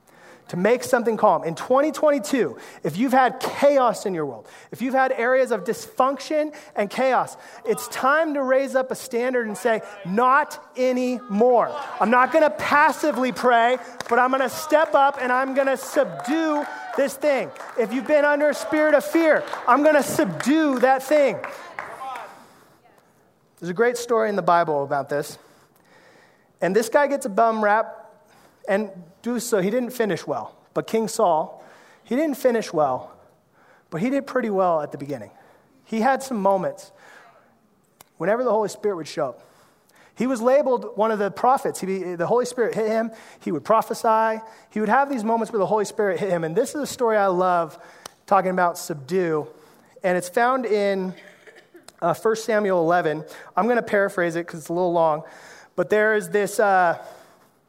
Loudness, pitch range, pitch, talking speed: -22 LUFS, 195-265 Hz, 230 Hz, 175 wpm